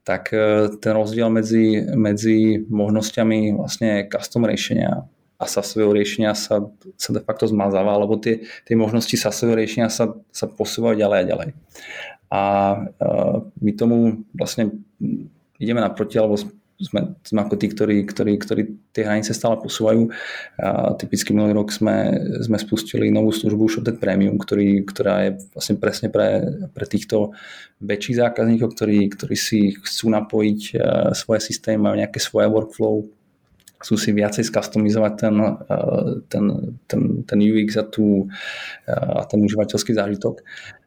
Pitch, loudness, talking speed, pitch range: 110 Hz, -20 LUFS, 135 wpm, 105-110 Hz